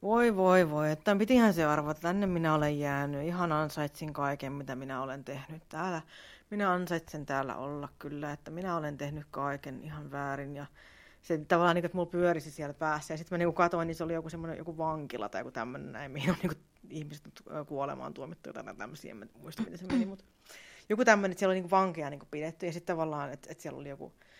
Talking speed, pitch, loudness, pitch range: 210 wpm, 160 Hz, -32 LUFS, 145-175 Hz